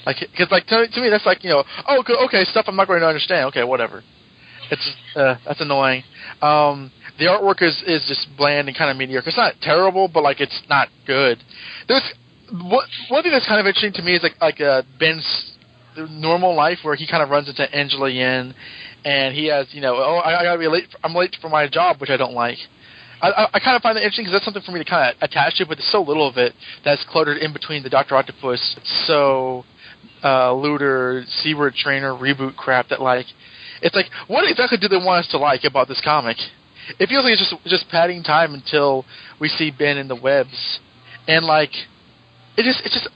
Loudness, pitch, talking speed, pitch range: -18 LUFS, 150 Hz, 225 wpm, 135-180 Hz